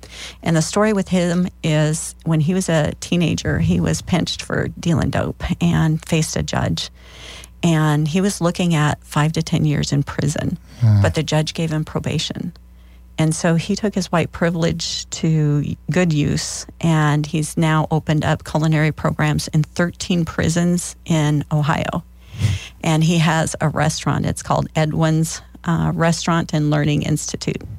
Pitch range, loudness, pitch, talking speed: 150-170 Hz, -19 LUFS, 160 Hz, 160 wpm